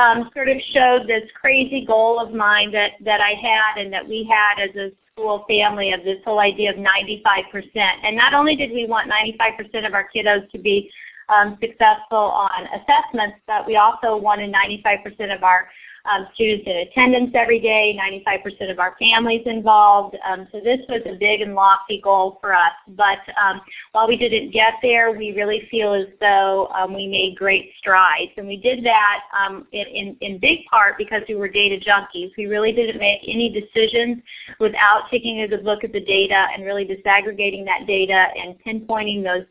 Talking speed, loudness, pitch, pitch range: 200 wpm, -18 LUFS, 210 Hz, 195-225 Hz